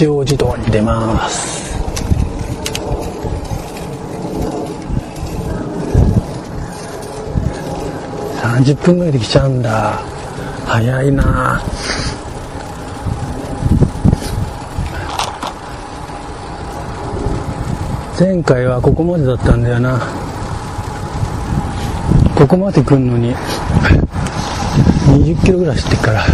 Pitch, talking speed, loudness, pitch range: 135 Hz, 130 characters per minute, -16 LUFS, 120-140 Hz